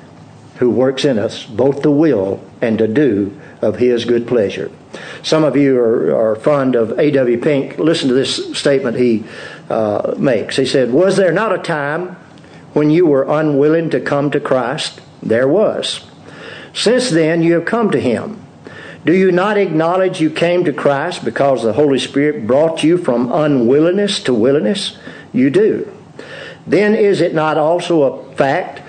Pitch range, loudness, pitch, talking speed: 125-170 Hz, -14 LUFS, 150 Hz, 170 wpm